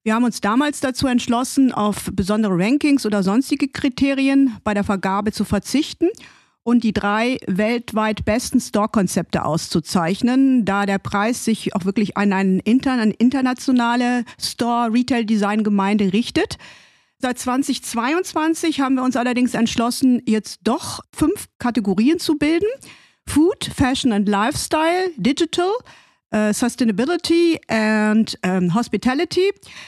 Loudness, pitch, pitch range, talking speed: -19 LUFS, 240 Hz, 210-270 Hz, 120 wpm